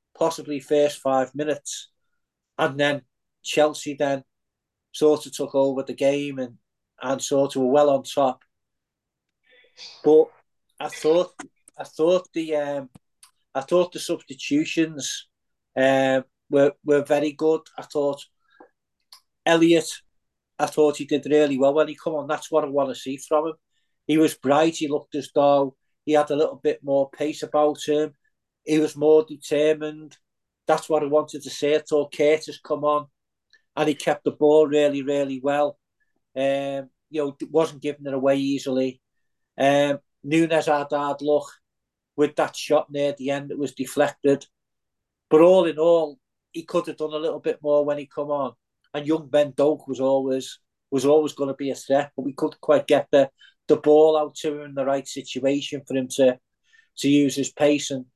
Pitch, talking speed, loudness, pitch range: 145 Hz, 175 wpm, -22 LUFS, 140-155 Hz